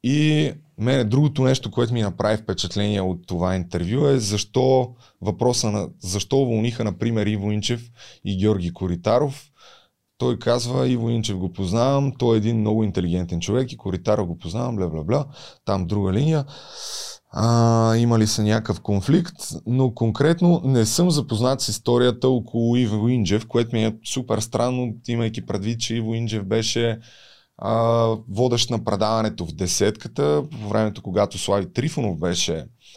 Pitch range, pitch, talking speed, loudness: 105-125 Hz, 115 Hz, 150 wpm, -22 LUFS